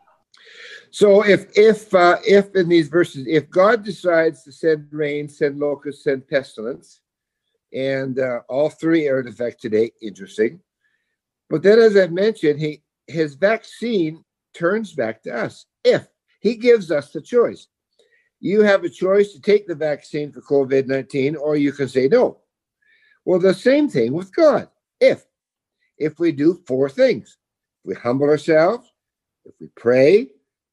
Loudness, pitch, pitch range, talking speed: -18 LUFS, 170 Hz, 145-215 Hz, 155 wpm